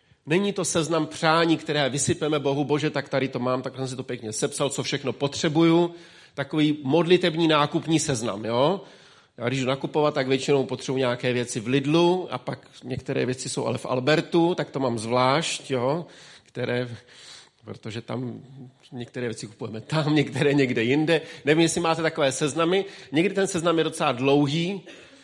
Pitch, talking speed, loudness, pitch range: 145 Hz, 170 wpm, -24 LUFS, 130-165 Hz